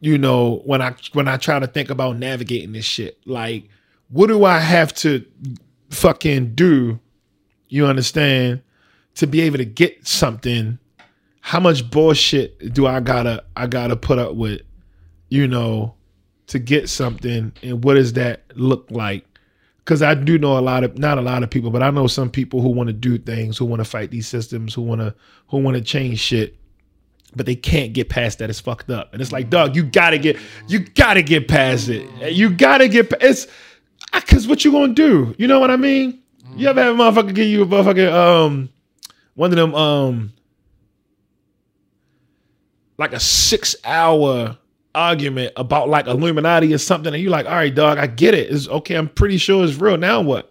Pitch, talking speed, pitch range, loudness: 135 Hz, 195 wpm, 120-160 Hz, -16 LUFS